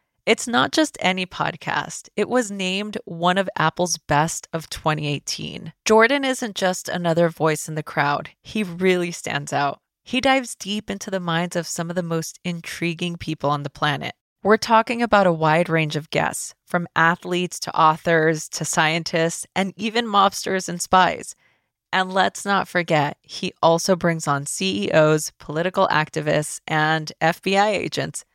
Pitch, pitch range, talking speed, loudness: 175 Hz, 160-195 Hz, 160 wpm, -21 LUFS